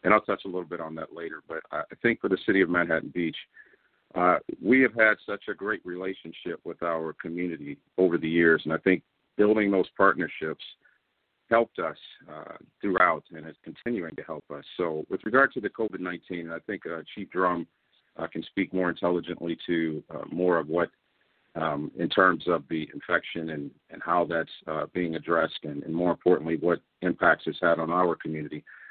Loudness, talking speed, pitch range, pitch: -27 LUFS, 195 wpm, 80-90 Hz, 85 Hz